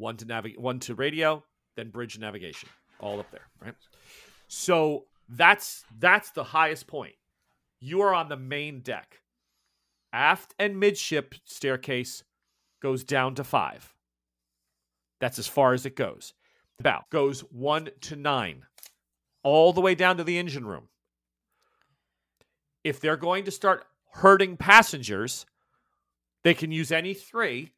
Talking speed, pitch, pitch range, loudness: 140 wpm, 140 Hz, 105-170 Hz, -25 LUFS